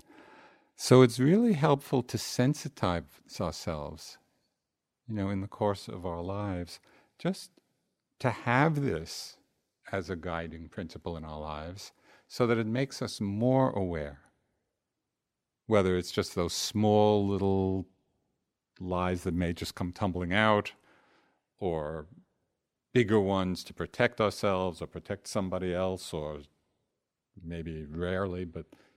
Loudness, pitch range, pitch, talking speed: -30 LUFS, 90-115 Hz, 95 Hz, 125 wpm